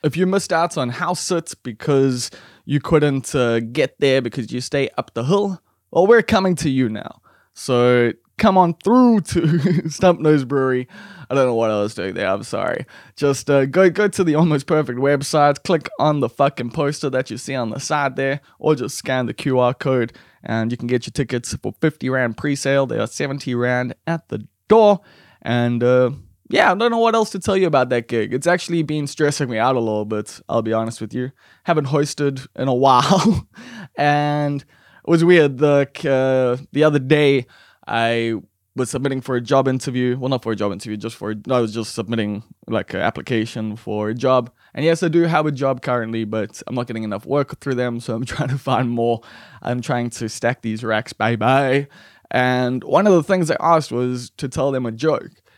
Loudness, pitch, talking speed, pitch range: -19 LUFS, 135 Hz, 215 wpm, 120-155 Hz